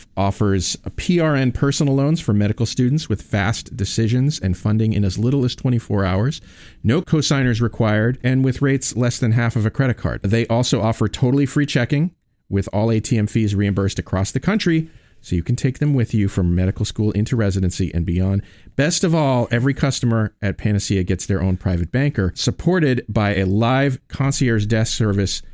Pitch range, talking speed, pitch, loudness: 100-135 Hz, 185 wpm, 115 Hz, -19 LUFS